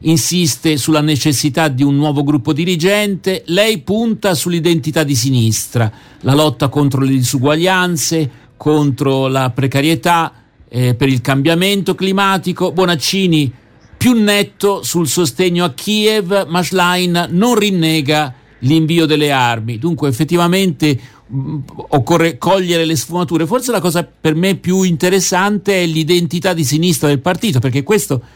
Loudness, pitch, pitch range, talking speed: -14 LUFS, 165 Hz, 145-180 Hz, 130 wpm